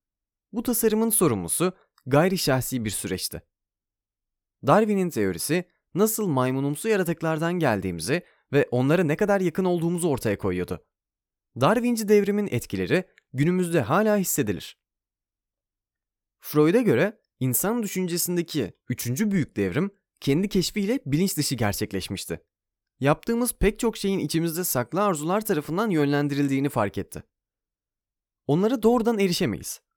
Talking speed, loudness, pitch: 105 wpm, -24 LUFS, 150 Hz